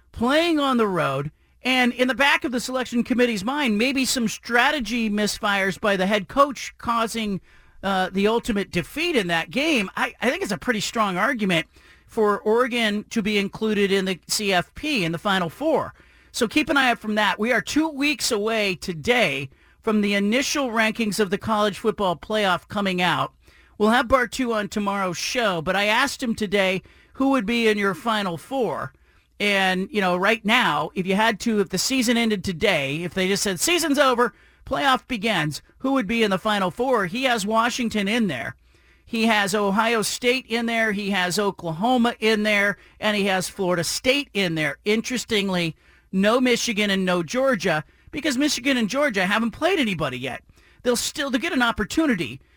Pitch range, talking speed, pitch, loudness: 195-245 Hz, 185 wpm, 215 Hz, -22 LUFS